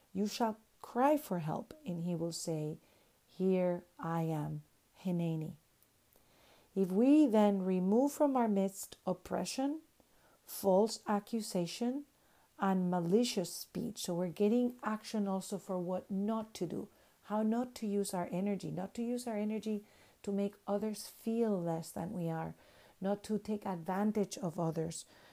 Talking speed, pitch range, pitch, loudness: 145 wpm, 175-215 Hz, 200 Hz, -36 LUFS